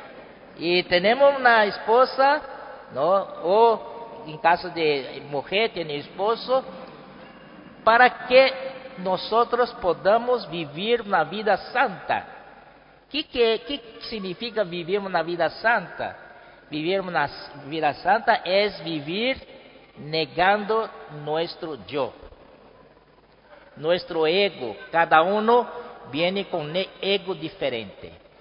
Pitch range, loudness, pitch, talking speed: 165-235 Hz, -23 LUFS, 195 Hz, 95 wpm